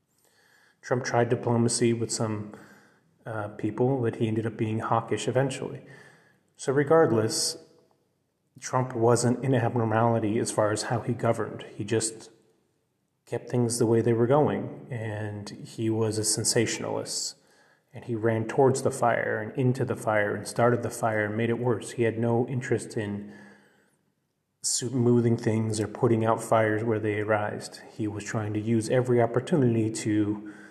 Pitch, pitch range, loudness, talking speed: 115 Hz, 110-125 Hz, -26 LUFS, 155 wpm